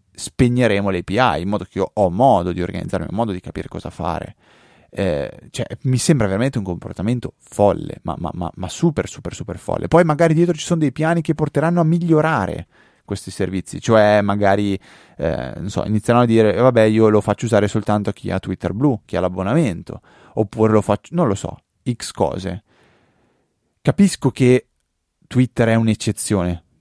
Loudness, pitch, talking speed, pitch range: -18 LUFS, 110 Hz, 180 wpm, 95-130 Hz